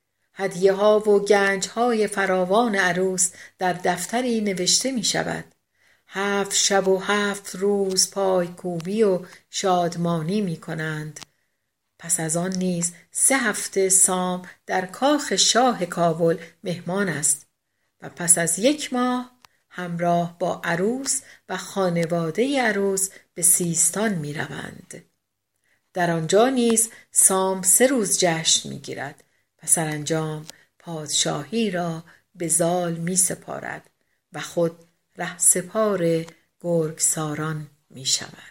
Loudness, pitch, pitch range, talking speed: -21 LUFS, 185 Hz, 170-200 Hz, 120 wpm